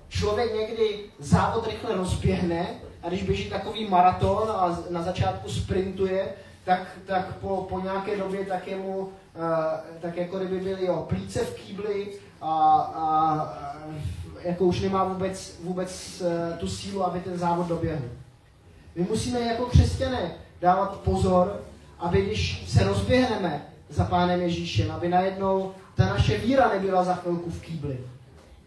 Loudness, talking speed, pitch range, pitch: -26 LUFS, 145 wpm, 160-190 Hz, 180 Hz